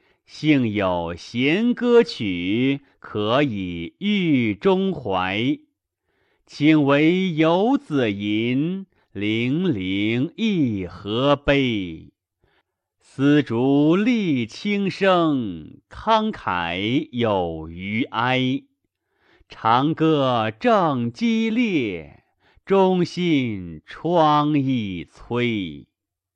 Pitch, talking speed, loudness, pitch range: 140 Hz, 90 characters per minute, -21 LUFS, 110-180 Hz